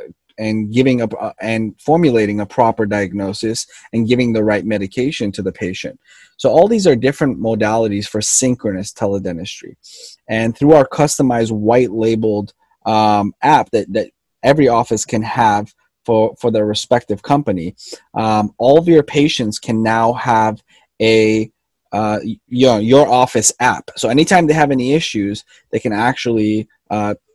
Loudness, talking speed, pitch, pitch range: -15 LUFS, 155 wpm, 110 Hz, 105-130 Hz